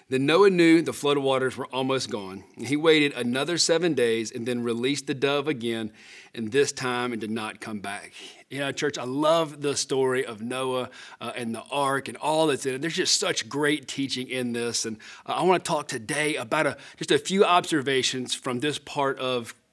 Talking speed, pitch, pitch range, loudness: 210 wpm, 130 Hz, 120-145 Hz, -25 LUFS